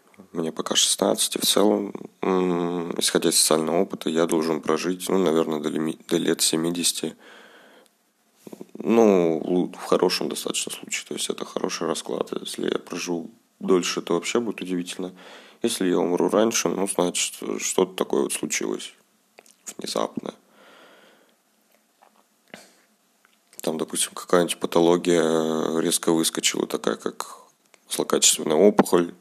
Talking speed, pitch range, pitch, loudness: 120 wpm, 80-95 Hz, 85 Hz, -23 LUFS